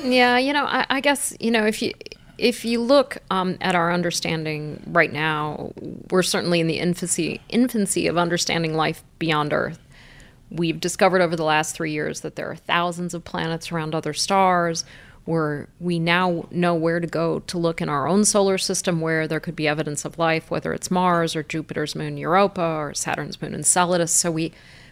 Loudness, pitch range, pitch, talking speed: -22 LUFS, 160-185 Hz, 170 Hz, 195 wpm